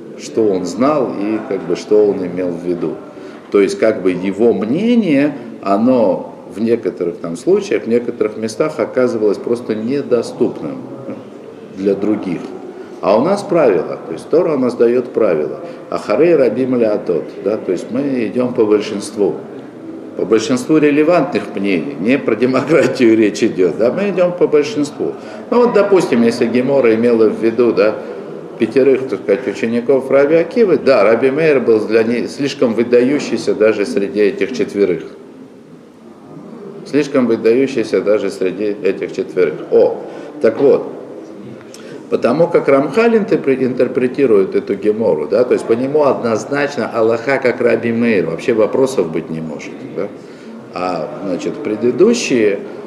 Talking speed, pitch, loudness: 145 wpm, 125 Hz, -15 LUFS